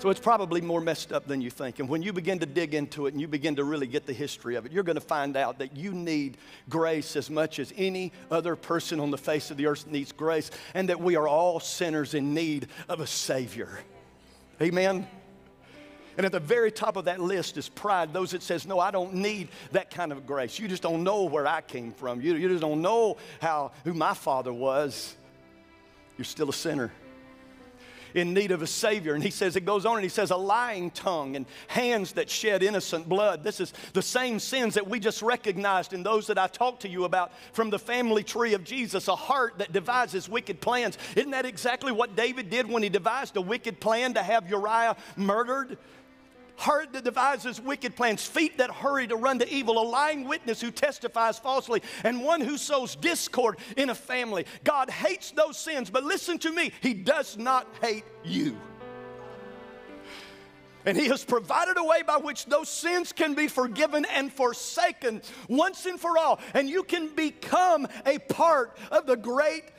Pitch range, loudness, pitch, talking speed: 160-250 Hz, -28 LUFS, 205 Hz, 205 wpm